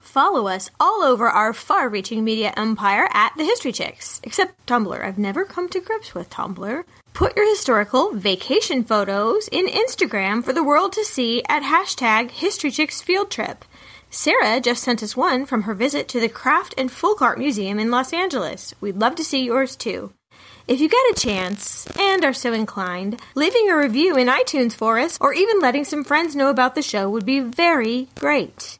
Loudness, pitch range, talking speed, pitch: -20 LUFS, 220-330 Hz, 190 wpm, 255 Hz